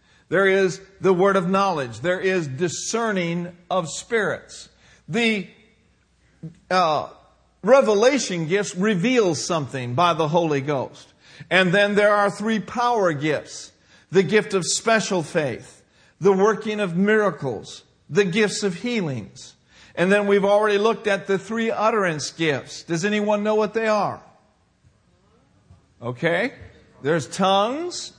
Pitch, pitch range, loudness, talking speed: 195 Hz, 170-210 Hz, -21 LUFS, 130 wpm